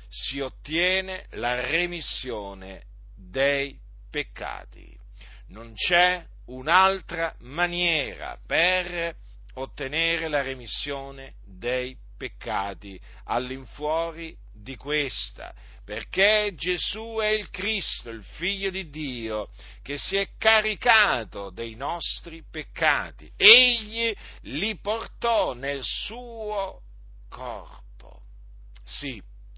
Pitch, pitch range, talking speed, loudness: 150 Hz, 115-190 Hz, 85 wpm, -25 LUFS